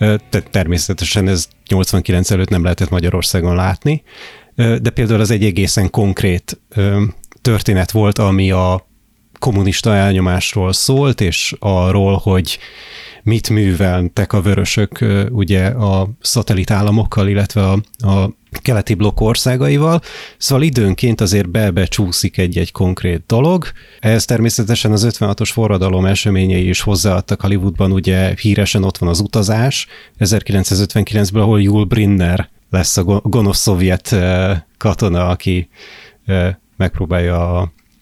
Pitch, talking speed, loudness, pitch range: 100 Hz, 115 wpm, -14 LUFS, 95-110 Hz